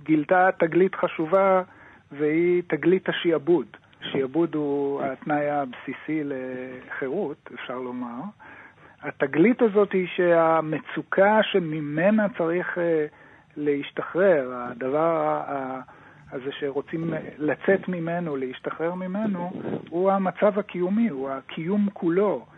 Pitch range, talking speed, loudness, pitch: 145-185 Hz, 90 wpm, -24 LUFS, 165 Hz